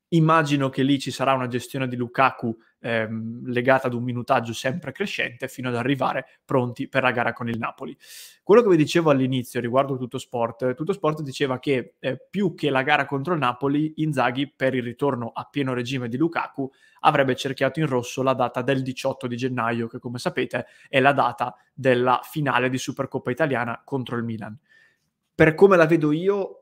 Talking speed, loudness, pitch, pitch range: 190 wpm, -23 LUFS, 130 Hz, 125-145 Hz